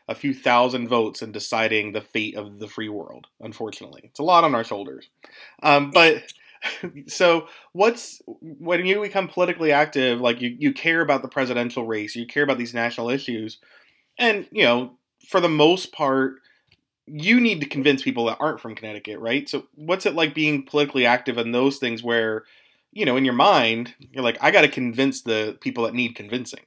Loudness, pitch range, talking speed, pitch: -21 LUFS, 115-160 Hz, 195 wpm, 135 Hz